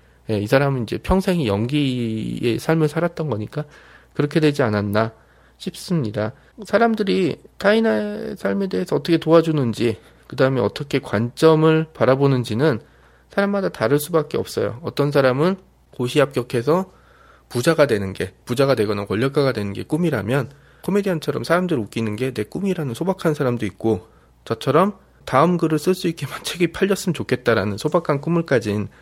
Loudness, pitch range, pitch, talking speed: -20 LUFS, 115-165 Hz, 140 Hz, 355 characters per minute